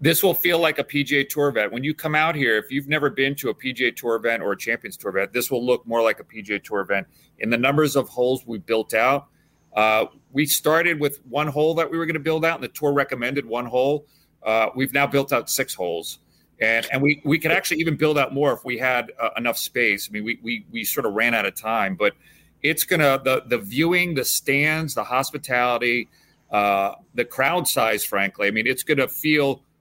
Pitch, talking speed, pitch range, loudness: 140 Hz, 235 wpm, 120-155 Hz, -22 LUFS